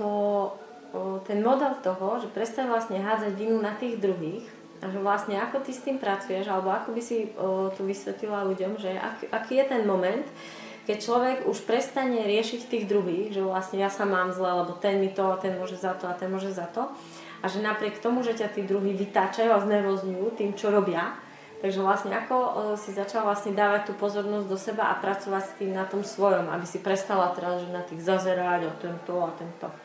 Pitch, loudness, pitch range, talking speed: 200 Hz, -28 LUFS, 190-215 Hz, 215 wpm